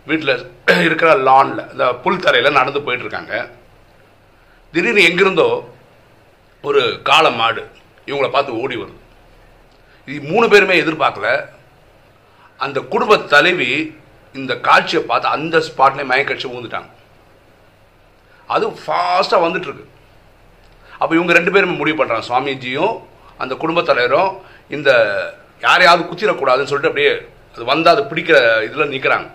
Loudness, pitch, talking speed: -15 LUFS, 180 Hz, 110 wpm